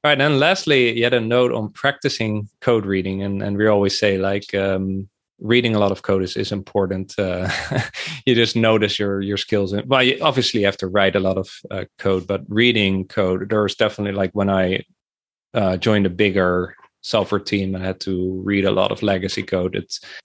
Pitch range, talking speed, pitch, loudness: 95-110 Hz, 205 wpm, 100 Hz, -19 LUFS